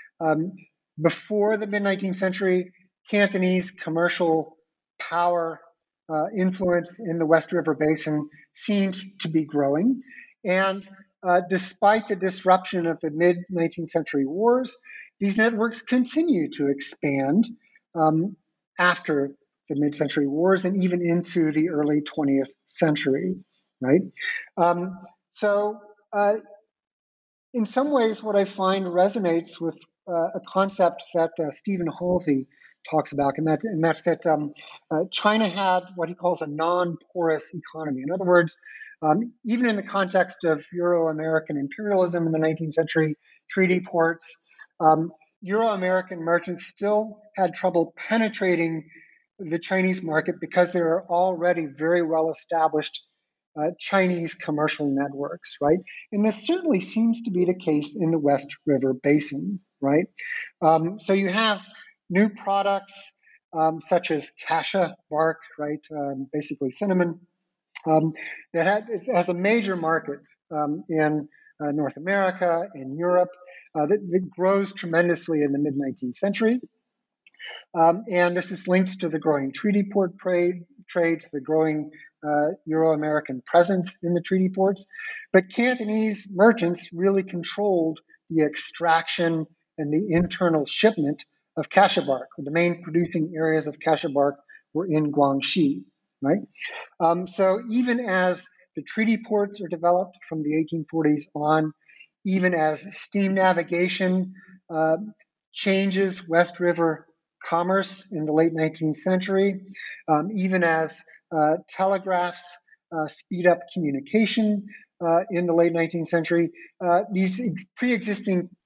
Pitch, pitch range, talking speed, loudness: 175 Hz, 160-195 Hz, 135 wpm, -24 LUFS